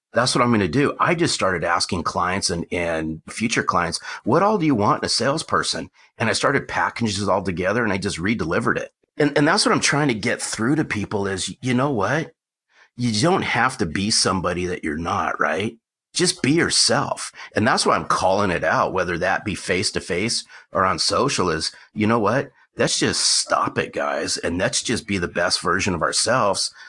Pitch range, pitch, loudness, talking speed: 90-115 Hz, 100 Hz, -21 LUFS, 215 wpm